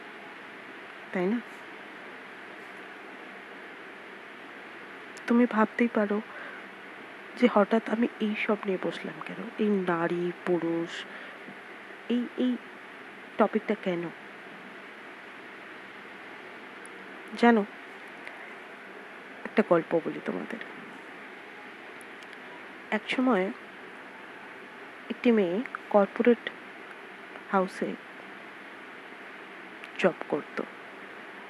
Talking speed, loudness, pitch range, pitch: 50 wpm, -29 LUFS, 190-240 Hz, 215 Hz